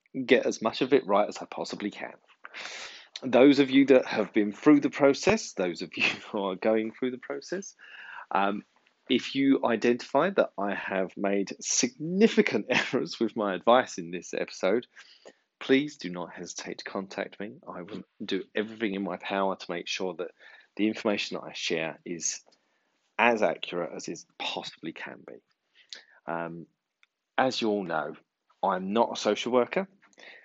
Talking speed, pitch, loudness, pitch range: 170 wpm, 110 Hz, -27 LUFS, 95-140 Hz